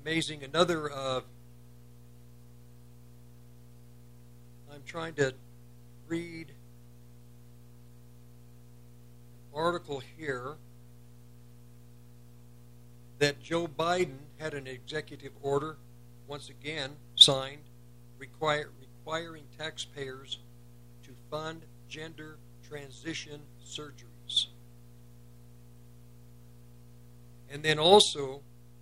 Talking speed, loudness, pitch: 65 wpm, -30 LUFS, 120 Hz